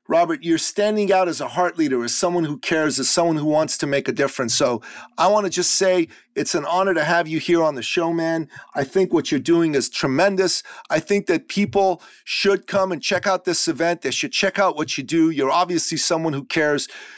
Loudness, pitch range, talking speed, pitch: -20 LUFS, 155-195 Hz, 235 wpm, 175 Hz